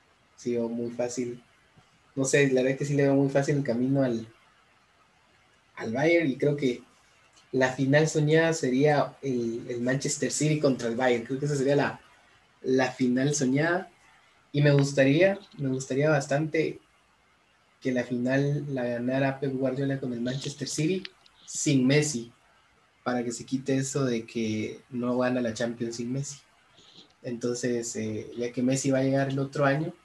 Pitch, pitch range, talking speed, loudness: 130 Hz, 125-145 Hz, 170 wpm, -27 LUFS